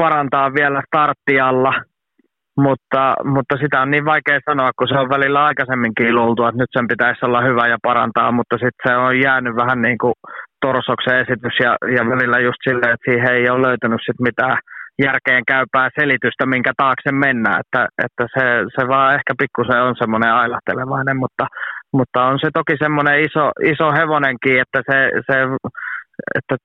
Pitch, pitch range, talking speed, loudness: 130 Hz, 125-140 Hz, 170 wpm, -16 LUFS